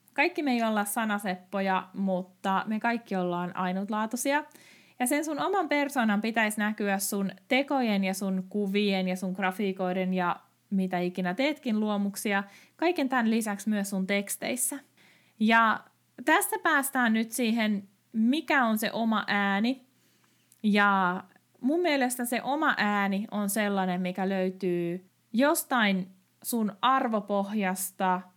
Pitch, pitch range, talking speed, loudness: 210 Hz, 190-250 Hz, 125 wpm, -28 LUFS